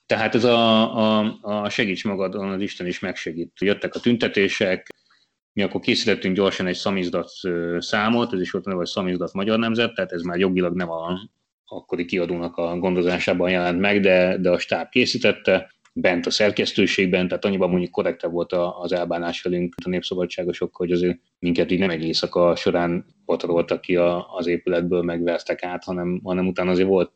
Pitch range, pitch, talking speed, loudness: 85-95 Hz, 90 Hz, 170 wpm, -22 LUFS